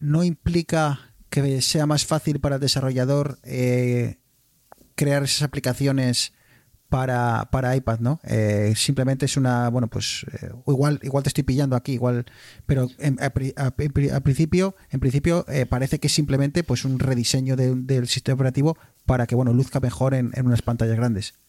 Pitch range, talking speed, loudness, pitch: 125-140 Hz, 175 wpm, -22 LUFS, 130 Hz